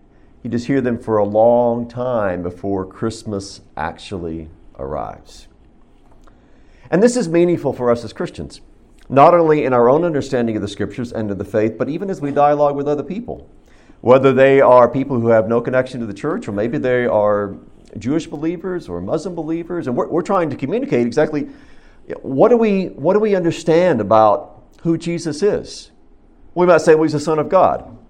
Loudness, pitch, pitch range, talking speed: -17 LUFS, 130 Hz, 110-165 Hz, 190 wpm